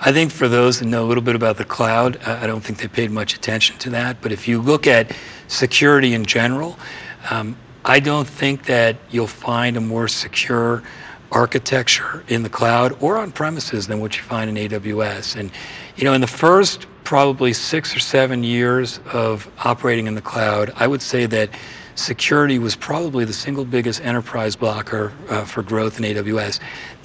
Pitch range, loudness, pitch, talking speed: 110-130 Hz, -18 LUFS, 120 Hz, 185 wpm